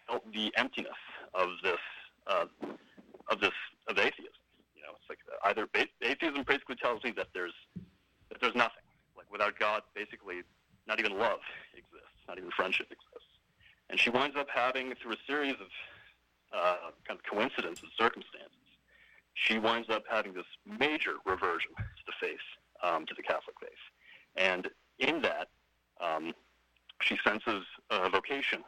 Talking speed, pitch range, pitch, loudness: 155 wpm, 90-145 Hz, 110 Hz, -33 LUFS